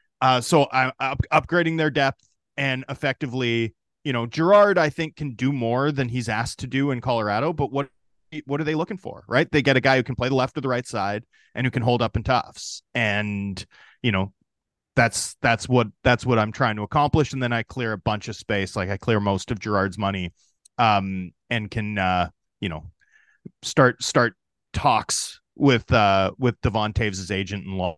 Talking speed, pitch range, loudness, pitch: 205 wpm, 105-140 Hz, -23 LUFS, 125 Hz